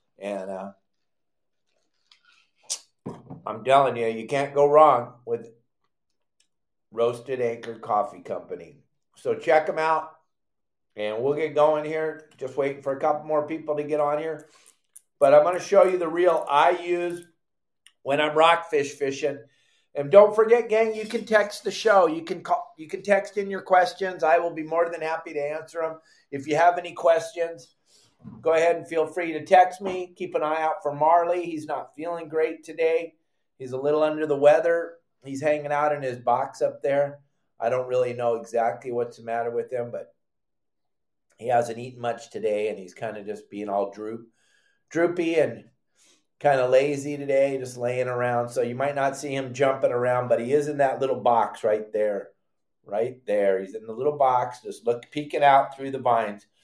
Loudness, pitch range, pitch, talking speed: -24 LUFS, 125-170 Hz, 150 Hz, 190 wpm